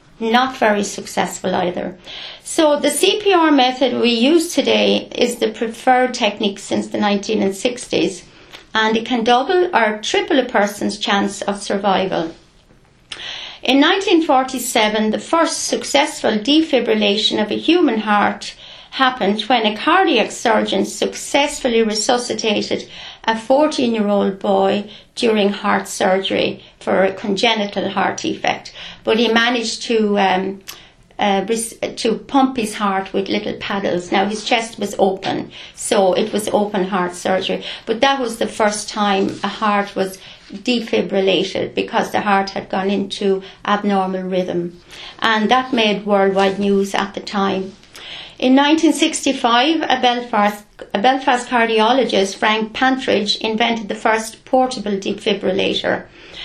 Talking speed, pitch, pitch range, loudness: 130 wpm, 220 Hz, 200-255 Hz, -17 LUFS